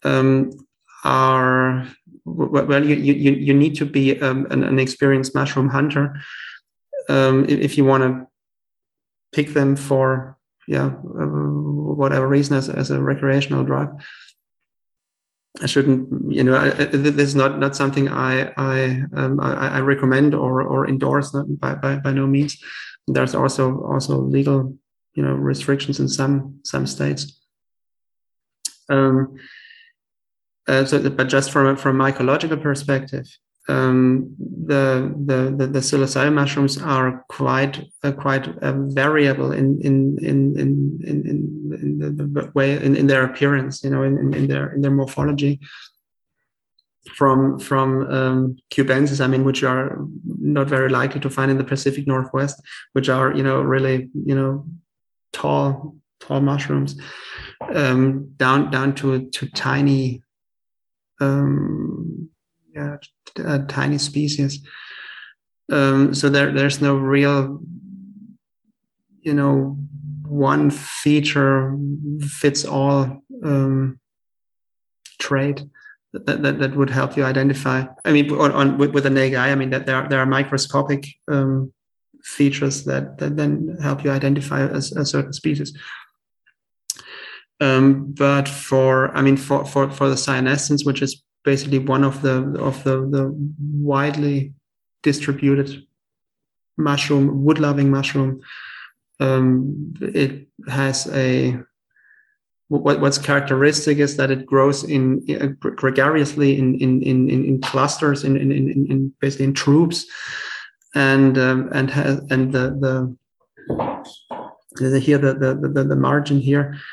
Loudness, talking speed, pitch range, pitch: -19 LUFS, 135 wpm, 135-145 Hz, 140 Hz